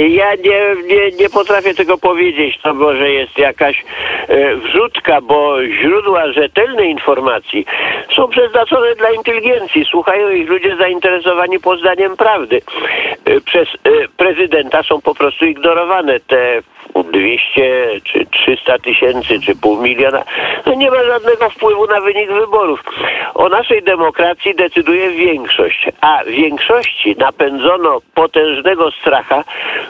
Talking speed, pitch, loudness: 115 wpm, 200 Hz, -12 LUFS